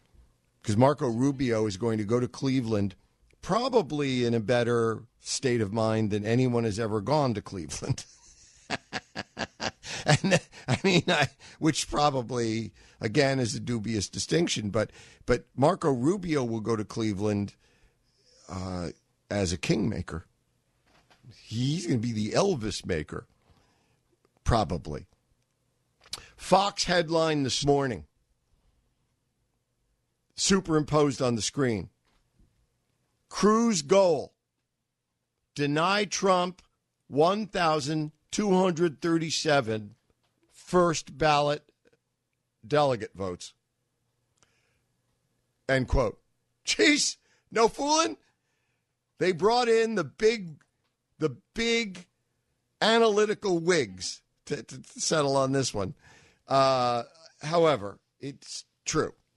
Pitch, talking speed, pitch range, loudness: 130 Hz, 95 wpm, 110-160 Hz, -27 LUFS